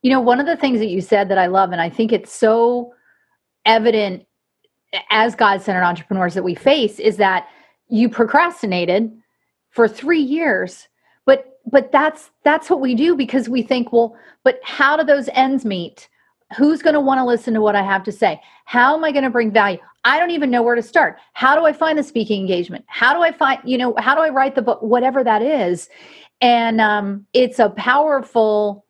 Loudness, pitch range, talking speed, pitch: -16 LUFS, 210-270 Hz, 210 wpm, 240 Hz